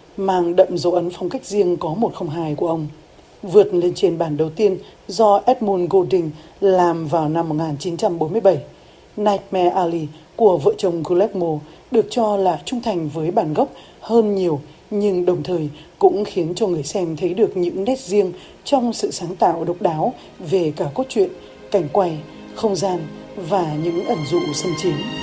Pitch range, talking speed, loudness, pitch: 165-200 Hz, 175 wpm, -19 LUFS, 180 Hz